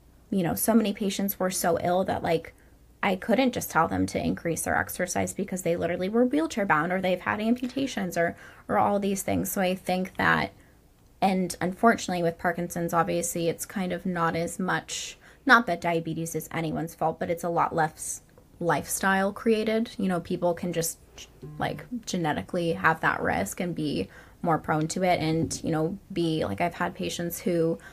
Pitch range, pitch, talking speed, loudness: 165-195 Hz, 175 Hz, 185 wpm, -27 LUFS